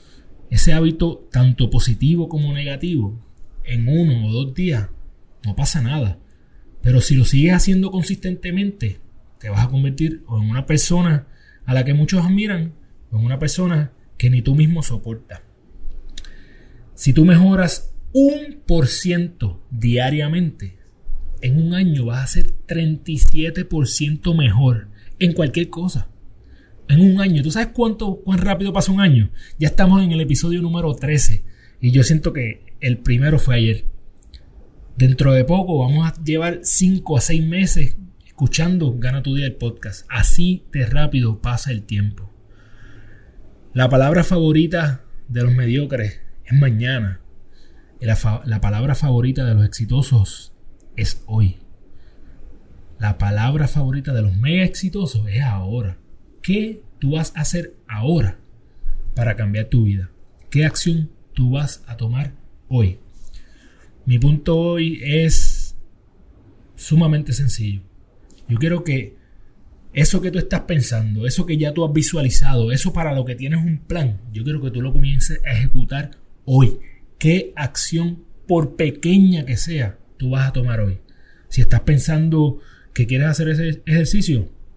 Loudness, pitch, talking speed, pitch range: -19 LUFS, 135 Hz, 145 wpm, 110-160 Hz